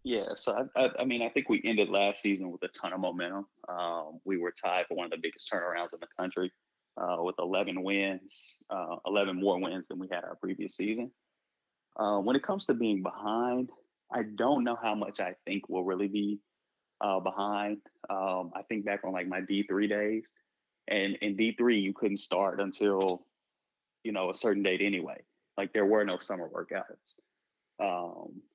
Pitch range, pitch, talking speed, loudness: 95-105 Hz, 100 Hz, 195 wpm, -32 LUFS